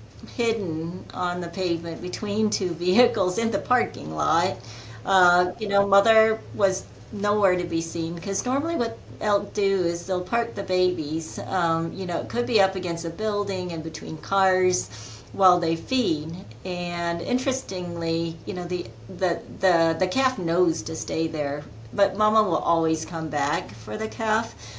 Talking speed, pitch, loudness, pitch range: 165 wpm, 180 Hz, -24 LUFS, 165-200 Hz